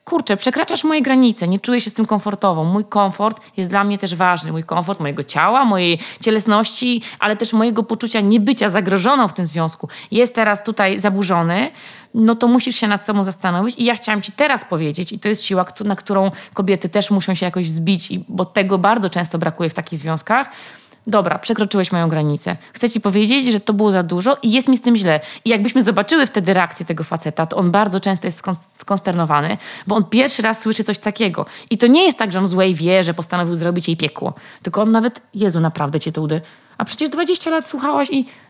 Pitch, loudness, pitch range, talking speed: 205 Hz, -17 LUFS, 180-230 Hz, 210 wpm